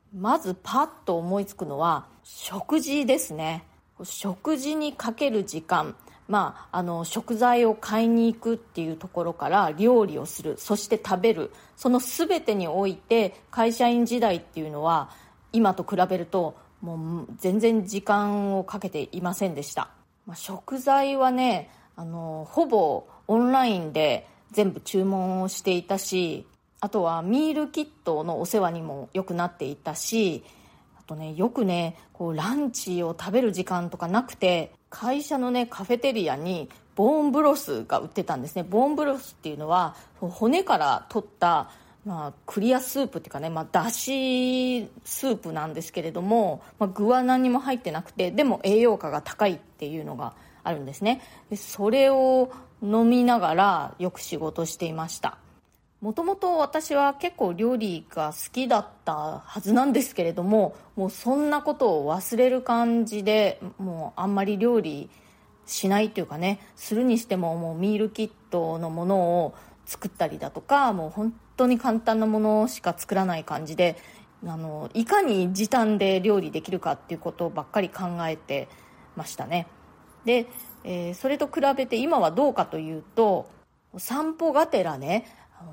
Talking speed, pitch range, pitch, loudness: 315 characters per minute, 175-245 Hz, 205 Hz, -25 LUFS